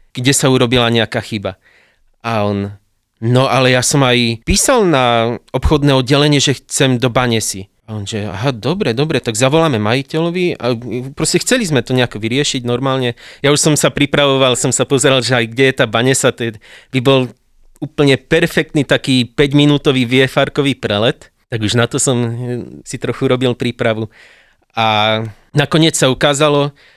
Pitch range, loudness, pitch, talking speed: 115-145 Hz, -14 LUFS, 130 Hz, 165 wpm